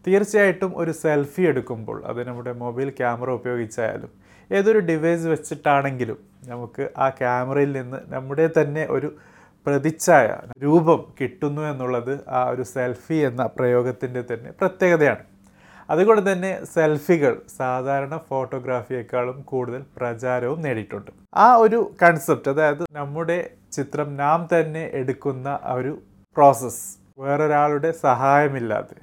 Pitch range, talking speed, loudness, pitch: 125-160 Hz, 105 wpm, -21 LUFS, 140 Hz